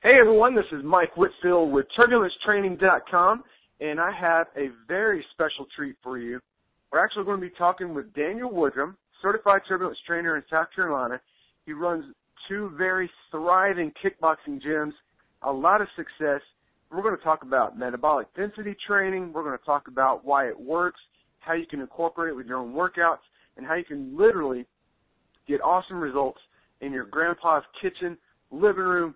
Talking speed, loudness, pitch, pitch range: 170 wpm, -25 LUFS, 165 Hz, 145-185 Hz